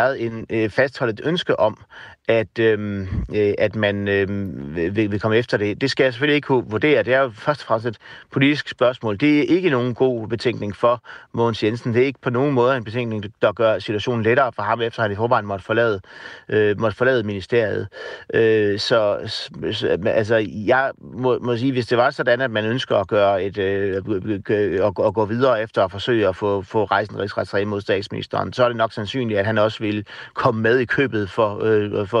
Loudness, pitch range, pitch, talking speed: -20 LUFS, 105-125 Hz, 115 Hz, 220 wpm